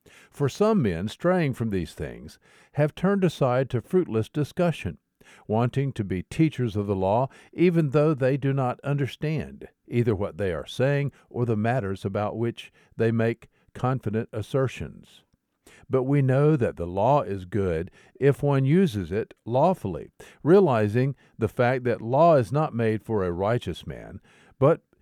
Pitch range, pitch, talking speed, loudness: 110-145 Hz, 125 Hz, 160 wpm, -25 LUFS